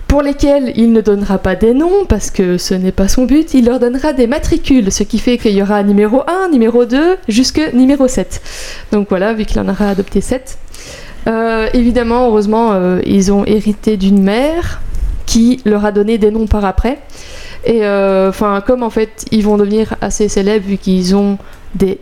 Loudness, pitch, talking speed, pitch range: -12 LUFS, 220 Hz, 195 wpm, 200-250 Hz